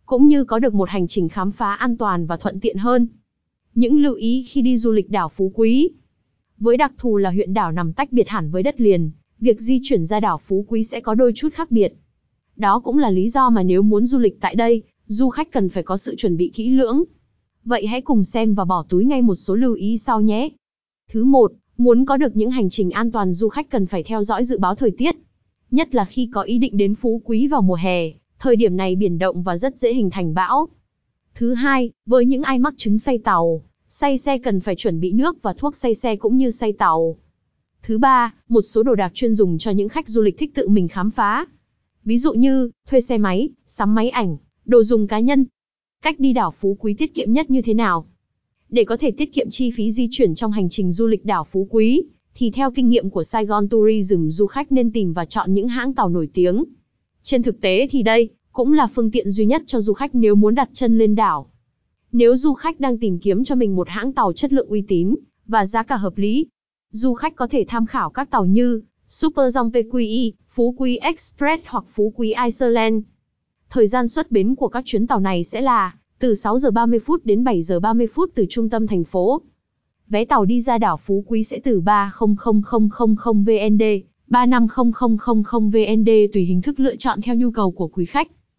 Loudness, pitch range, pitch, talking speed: -18 LUFS, 205-255 Hz, 225 Hz, 230 wpm